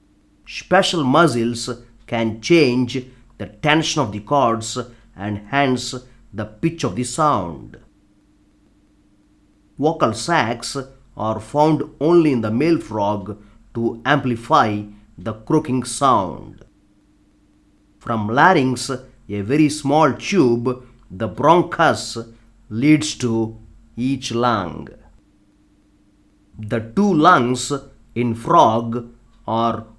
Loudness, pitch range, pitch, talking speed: -18 LUFS, 105-135 Hz, 115 Hz, 95 wpm